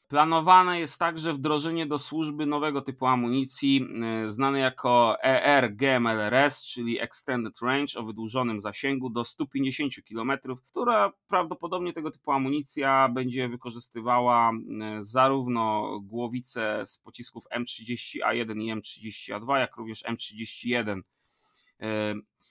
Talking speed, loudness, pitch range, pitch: 105 wpm, -27 LUFS, 115-140 Hz, 130 Hz